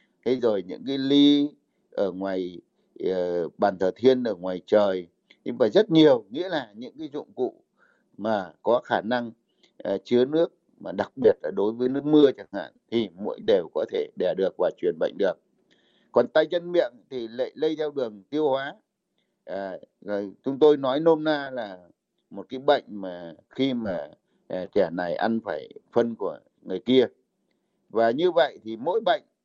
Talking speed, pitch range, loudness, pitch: 185 wpm, 110-165 Hz, -25 LUFS, 135 Hz